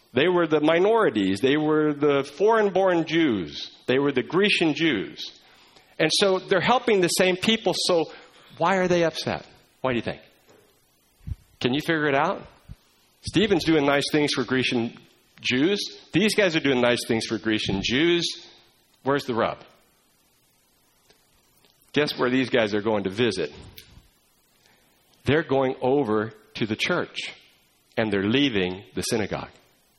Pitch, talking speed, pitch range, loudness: 140 Hz, 150 wpm, 115-165 Hz, -23 LUFS